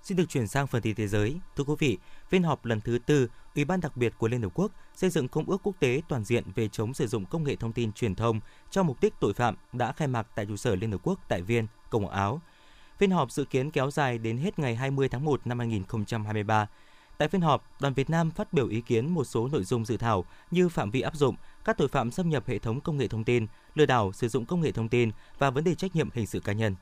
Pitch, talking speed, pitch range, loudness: 130 Hz, 275 wpm, 115-150 Hz, -29 LUFS